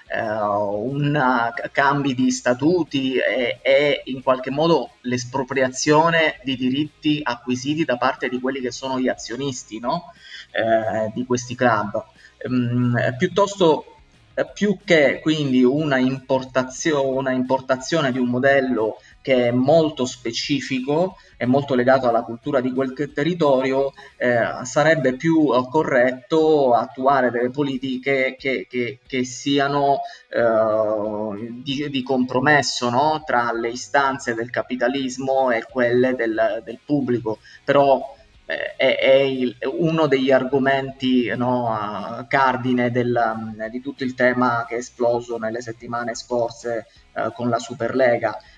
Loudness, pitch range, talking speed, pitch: -20 LUFS, 120-140 Hz, 130 wpm, 130 Hz